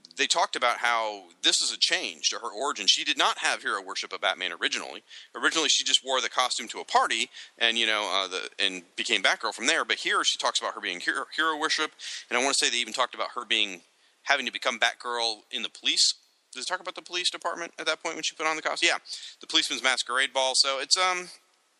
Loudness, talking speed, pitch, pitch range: -26 LUFS, 250 wpm, 140 Hz, 115-170 Hz